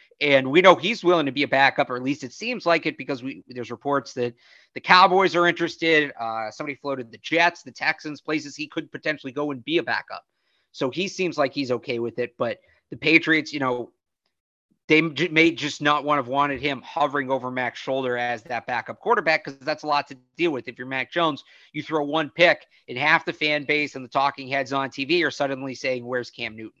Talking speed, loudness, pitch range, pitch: 230 wpm, -23 LUFS, 130-160 Hz, 145 Hz